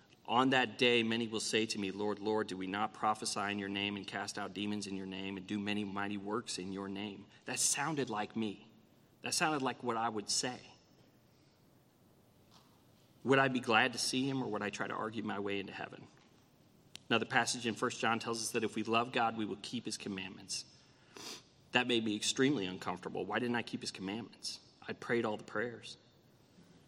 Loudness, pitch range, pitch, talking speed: -36 LUFS, 100-120 Hz, 110 Hz, 210 wpm